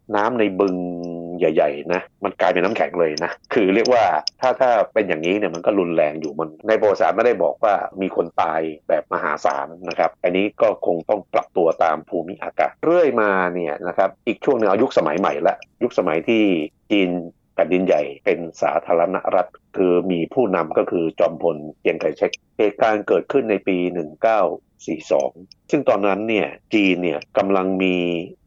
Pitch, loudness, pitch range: 90 Hz, -20 LUFS, 85-95 Hz